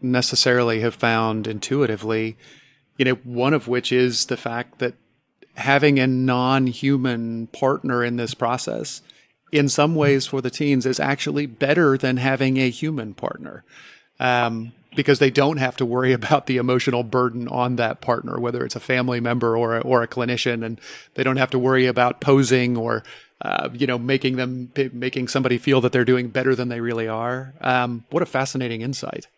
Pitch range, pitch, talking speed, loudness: 120-135 Hz, 125 Hz, 180 wpm, -21 LUFS